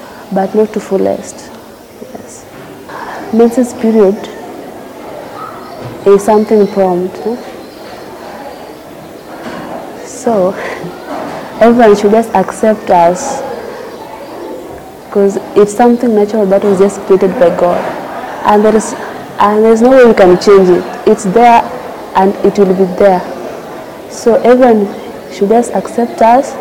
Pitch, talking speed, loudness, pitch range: 210 Hz, 115 wpm, -9 LUFS, 195-230 Hz